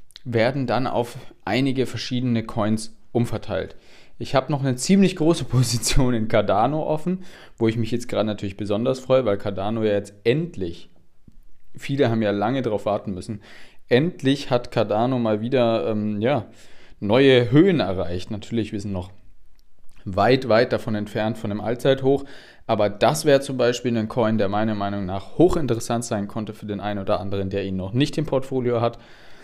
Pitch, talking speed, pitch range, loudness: 115 Hz, 170 wpm, 105-130 Hz, -22 LUFS